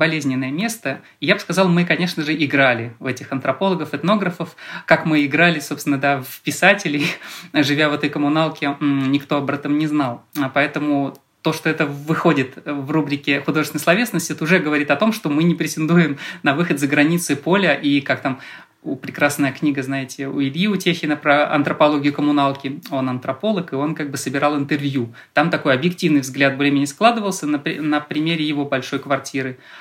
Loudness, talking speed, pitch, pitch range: -19 LUFS, 175 wpm, 150 Hz, 140-160 Hz